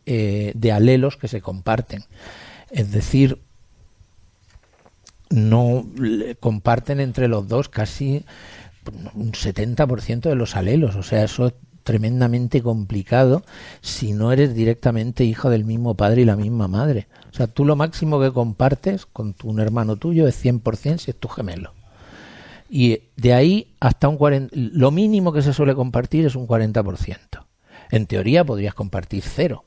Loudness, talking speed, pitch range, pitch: -20 LUFS, 155 wpm, 105-135 Hz, 115 Hz